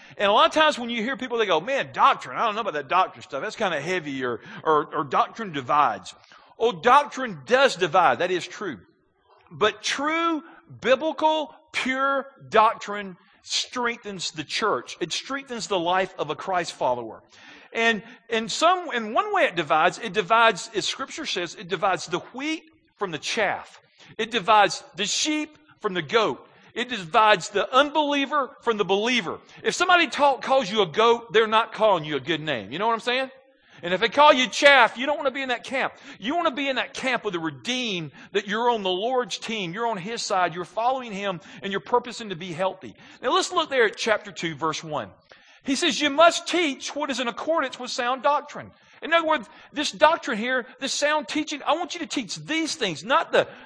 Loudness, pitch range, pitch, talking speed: -23 LUFS, 200-285 Hz, 240 Hz, 210 wpm